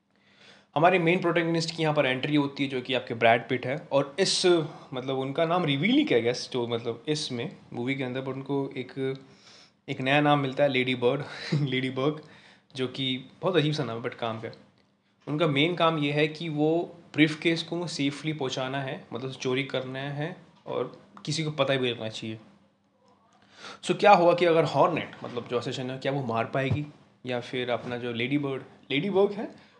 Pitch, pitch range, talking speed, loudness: 140 Hz, 130-160 Hz, 200 wpm, -27 LUFS